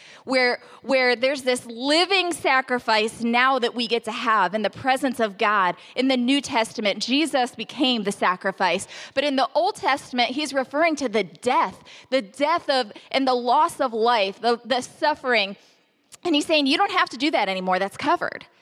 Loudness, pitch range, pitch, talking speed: -22 LUFS, 225-285 Hz, 255 Hz, 185 wpm